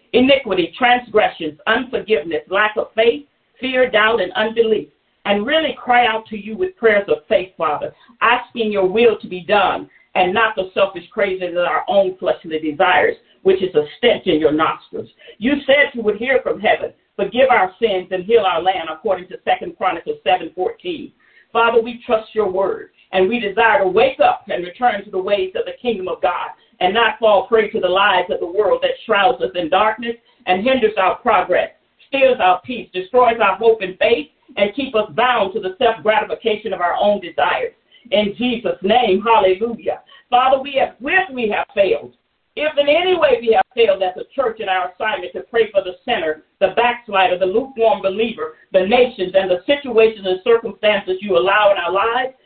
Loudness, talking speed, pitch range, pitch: -17 LUFS, 195 wpm, 190-250 Hz, 220 Hz